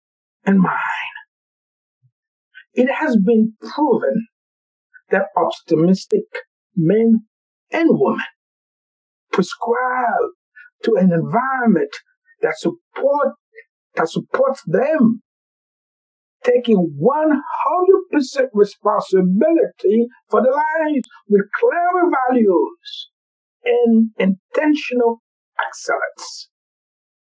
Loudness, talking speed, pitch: -18 LUFS, 75 wpm, 265 Hz